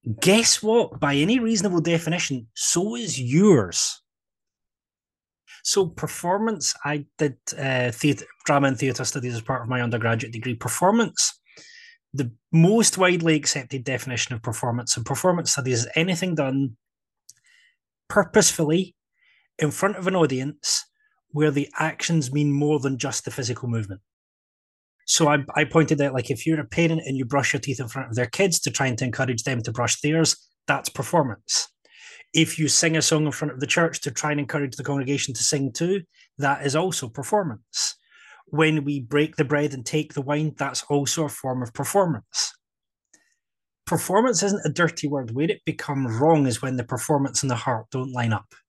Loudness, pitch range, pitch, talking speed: -23 LUFS, 130-165 Hz, 145 Hz, 175 wpm